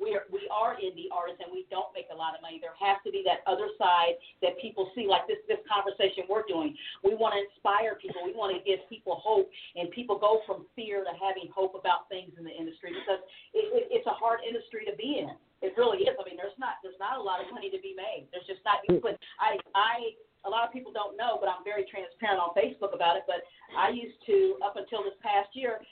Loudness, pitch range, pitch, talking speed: -31 LUFS, 185-285 Hz, 205 Hz, 250 wpm